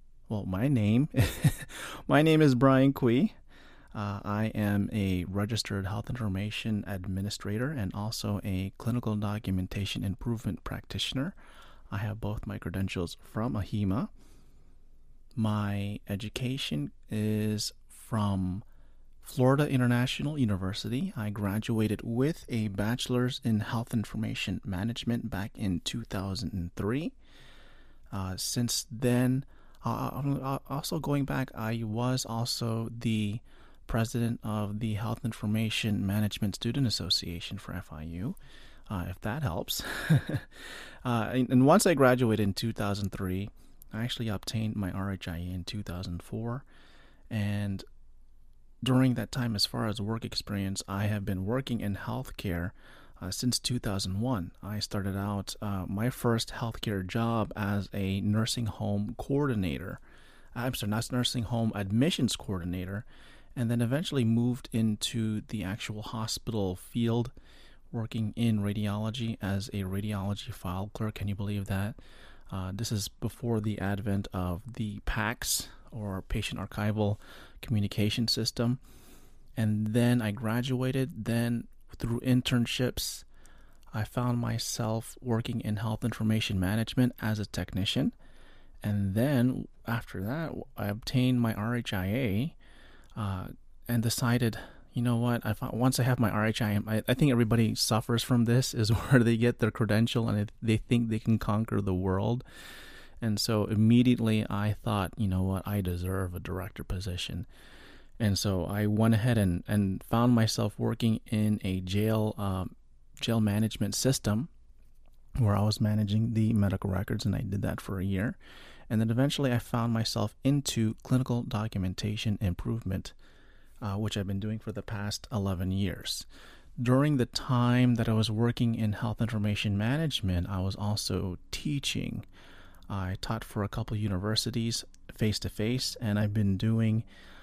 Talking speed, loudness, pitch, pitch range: 135 wpm, -30 LUFS, 110 Hz, 100-120 Hz